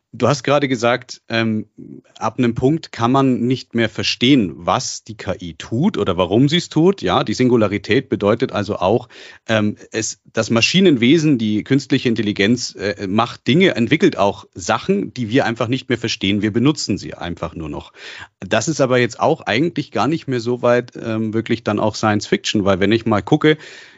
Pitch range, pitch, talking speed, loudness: 105-135 Hz, 115 Hz, 190 wpm, -17 LUFS